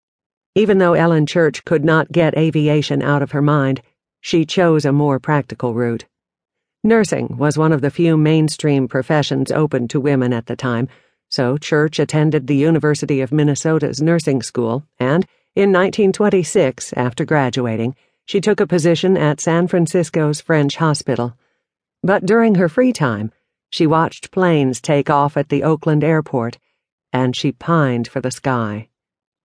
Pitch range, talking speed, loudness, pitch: 130-165 Hz, 155 wpm, -16 LUFS, 150 Hz